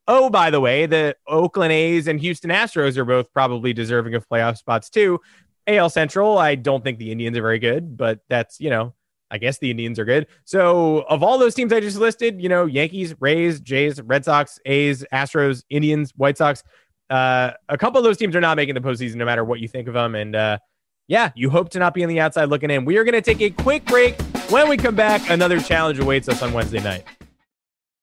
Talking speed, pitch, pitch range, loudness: 230 wpm, 145 Hz, 125-175 Hz, -19 LUFS